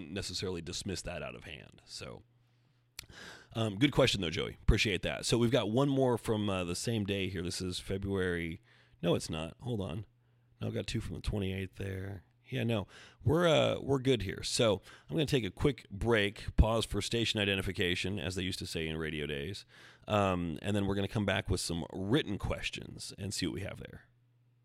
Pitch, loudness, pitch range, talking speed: 100 Hz, -33 LUFS, 95-120 Hz, 210 wpm